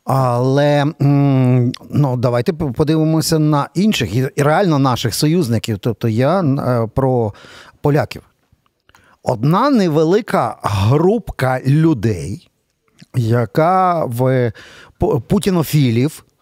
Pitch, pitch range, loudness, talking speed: 140 Hz, 125-160 Hz, -16 LUFS, 75 wpm